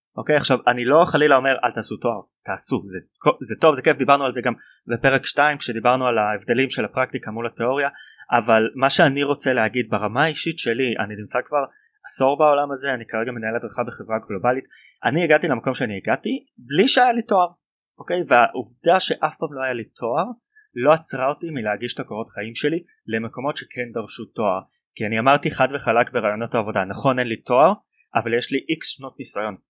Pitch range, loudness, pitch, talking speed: 115-145 Hz, -21 LUFS, 130 Hz, 195 wpm